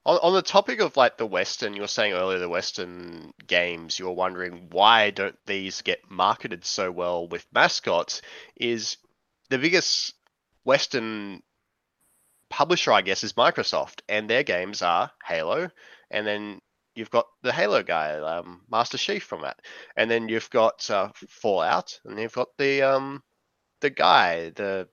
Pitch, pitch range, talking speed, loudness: 100 Hz, 90-115 Hz, 155 wpm, -24 LUFS